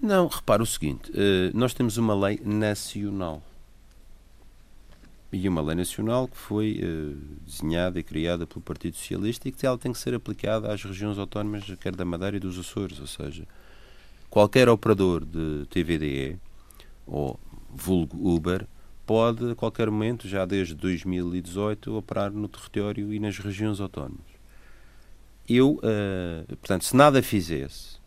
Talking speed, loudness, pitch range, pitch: 145 wpm, -26 LUFS, 85-110 Hz, 100 Hz